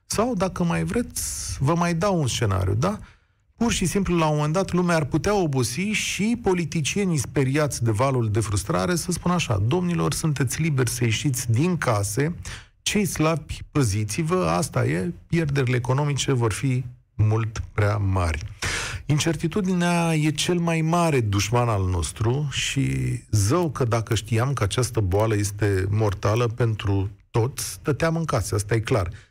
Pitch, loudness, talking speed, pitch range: 130 Hz, -23 LUFS, 160 wpm, 110-165 Hz